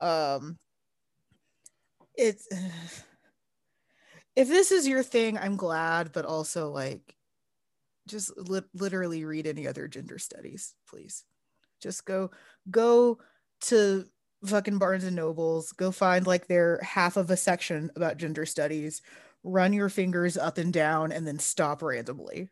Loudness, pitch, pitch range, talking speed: -28 LUFS, 180 Hz, 160-195 Hz, 135 wpm